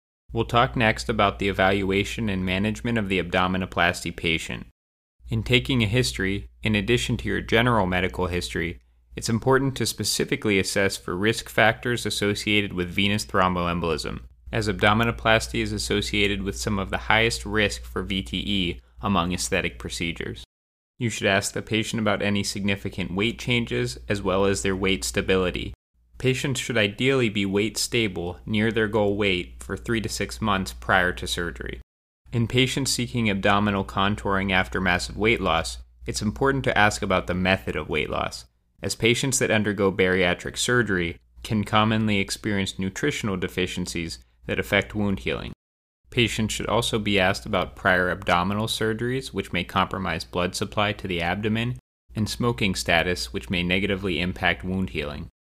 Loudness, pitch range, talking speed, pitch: -24 LUFS, 90-110 Hz, 155 wpm, 100 Hz